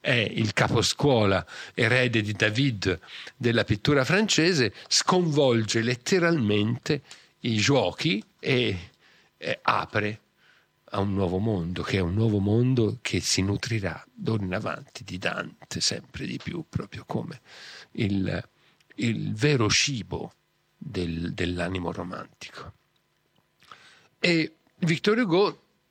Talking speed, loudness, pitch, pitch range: 110 wpm, -25 LUFS, 110 Hz, 95-135 Hz